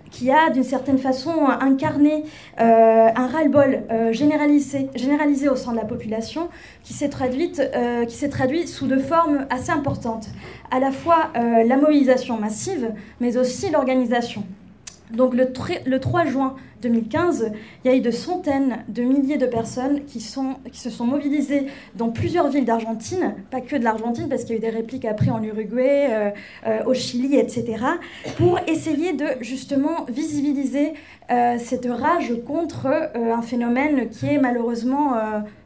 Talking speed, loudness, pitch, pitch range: 170 wpm, -21 LUFS, 260 Hz, 235-290 Hz